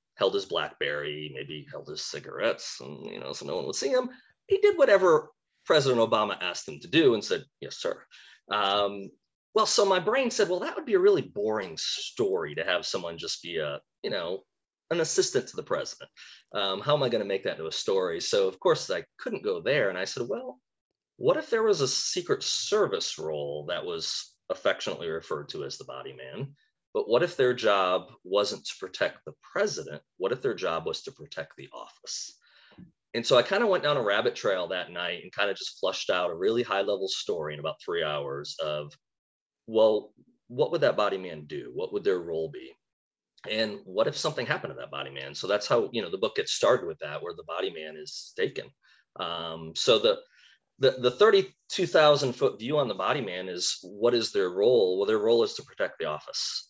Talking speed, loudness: 215 wpm, -28 LUFS